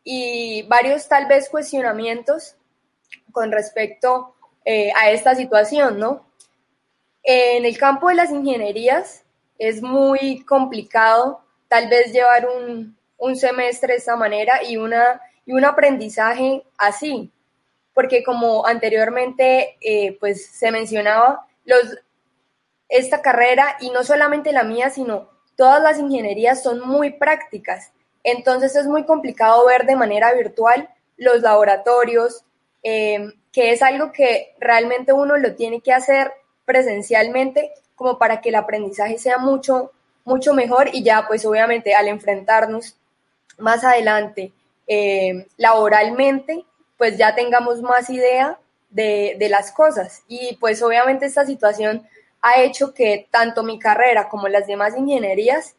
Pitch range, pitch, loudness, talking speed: 220-270 Hz, 245 Hz, -17 LUFS, 130 wpm